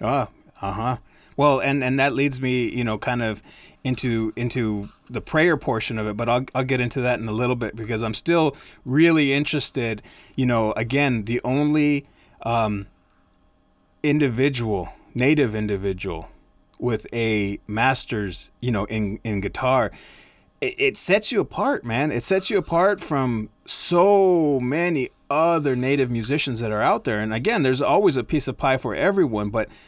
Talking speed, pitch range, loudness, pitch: 165 wpm, 110-145 Hz, -22 LUFS, 125 Hz